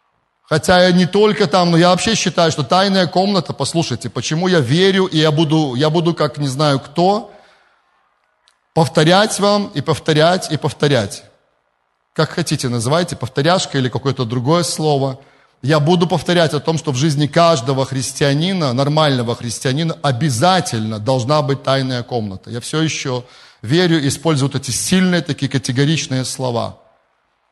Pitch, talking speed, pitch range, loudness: 150 Hz, 145 wpm, 130-170 Hz, -16 LUFS